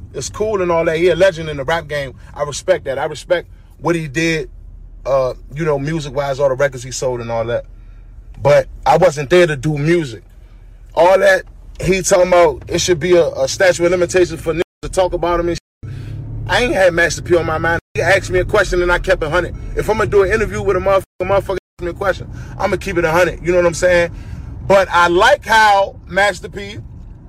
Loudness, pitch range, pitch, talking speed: -15 LUFS, 130-180 Hz, 170 Hz, 240 wpm